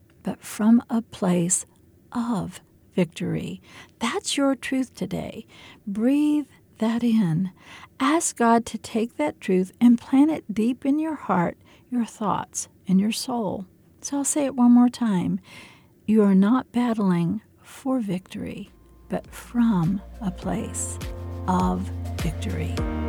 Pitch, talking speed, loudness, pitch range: 225 Hz, 130 wpm, -24 LUFS, 180-245 Hz